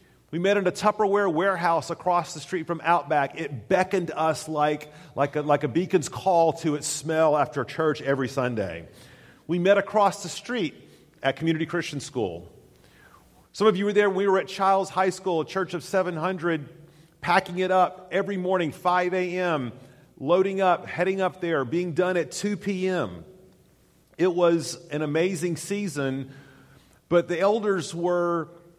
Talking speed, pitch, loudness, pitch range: 165 wpm, 175 Hz, -25 LUFS, 155-185 Hz